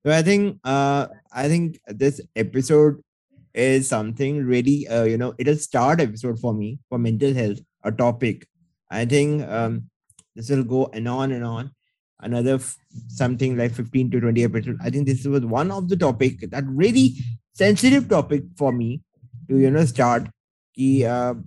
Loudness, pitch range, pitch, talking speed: -21 LUFS, 120-145 Hz, 130 Hz, 170 wpm